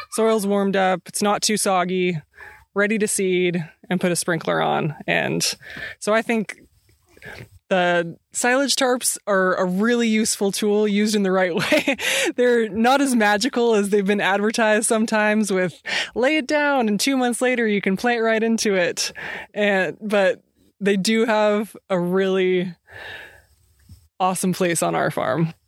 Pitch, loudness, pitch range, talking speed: 210 Hz, -20 LUFS, 185-230 Hz, 155 wpm